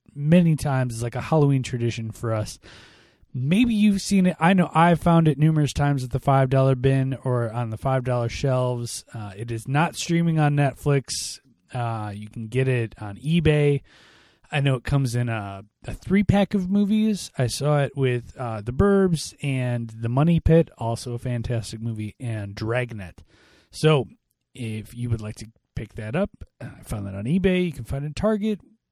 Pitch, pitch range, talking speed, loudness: 130 Hz, 115-155 Hz, 190 wpm, -23 LUFS